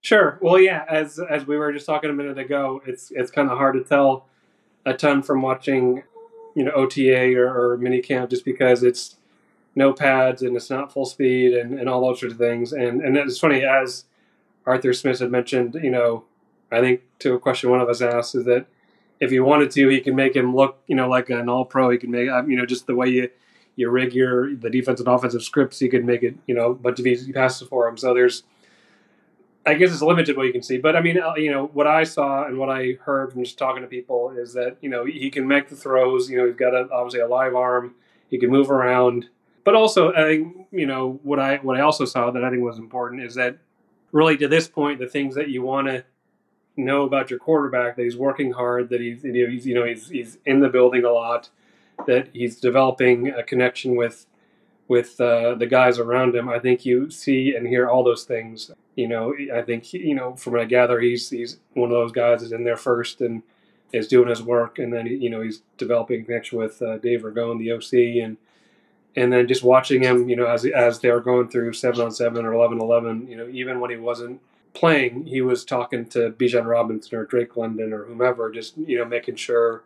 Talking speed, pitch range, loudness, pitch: 235 wpm, 120-135 Hz, -20 LUFS, 125 Hz